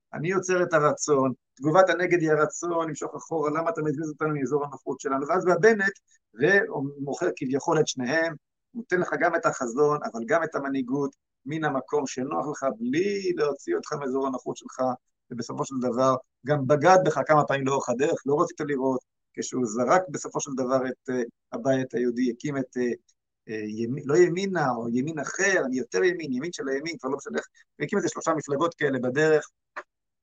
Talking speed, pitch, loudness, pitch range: 170 wpm, 150 Hz, -26 LUFS, 130-170 Hz